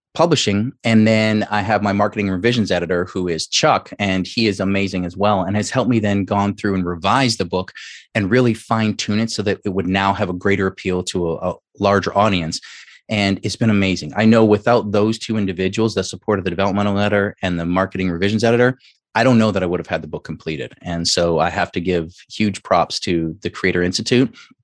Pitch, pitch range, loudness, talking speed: 100 Hz, 90-110 Hz, -18 LUFS, 220 wpm